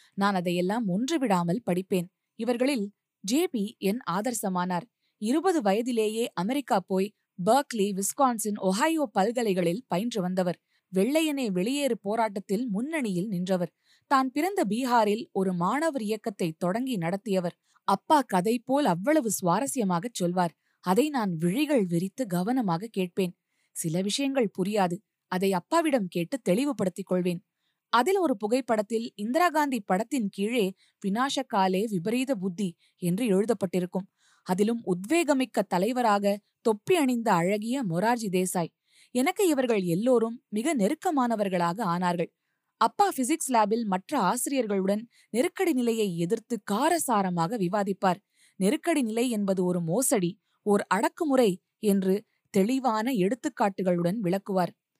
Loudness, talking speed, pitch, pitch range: -27 LUFS, 105 wpm, 210 Hz, 185-255 Hz